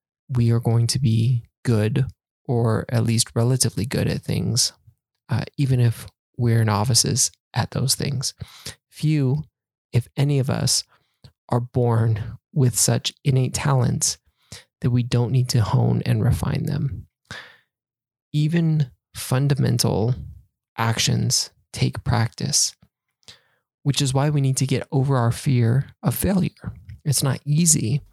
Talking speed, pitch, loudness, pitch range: 130 wpm, 125 Hz, -21 LUFS, 115-135 Hz